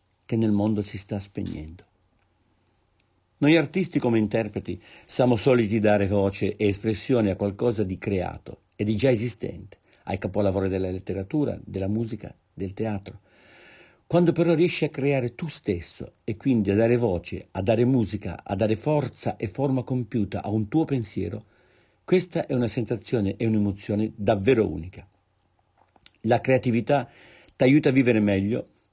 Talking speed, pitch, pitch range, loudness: 150 wpm, 110 Hz, 100-125 Hz, -25 LUFS